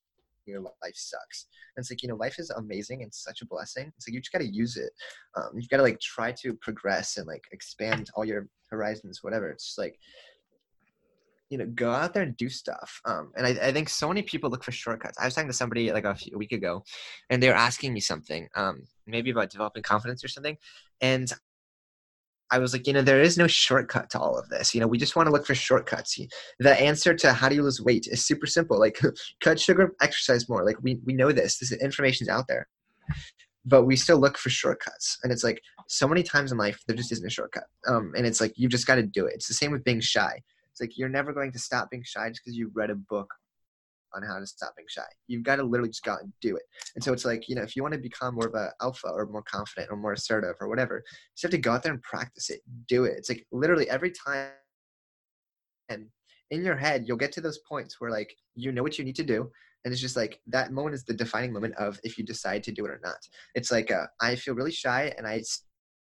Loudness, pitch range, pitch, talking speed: -27 LUFS, 115-135 Hz, 125 Hz, 260 wpm